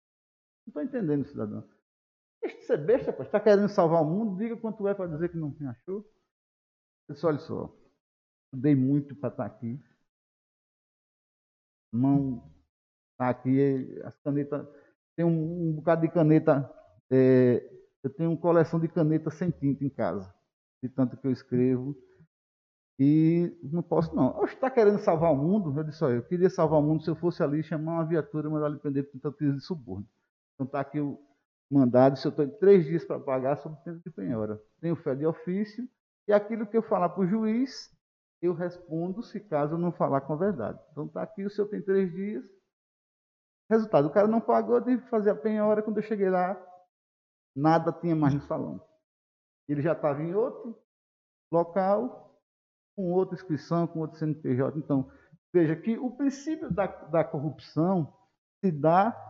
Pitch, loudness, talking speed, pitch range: 160 Hz, -28 LUFS, 175 wpm, 140-195 Hz